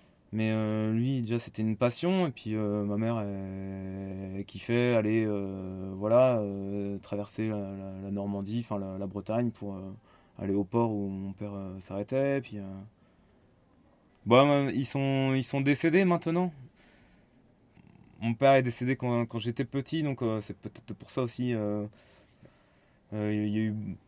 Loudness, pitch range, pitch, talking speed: -30 LUFS, 100-125 Hz, 110 Hz, 170 wpm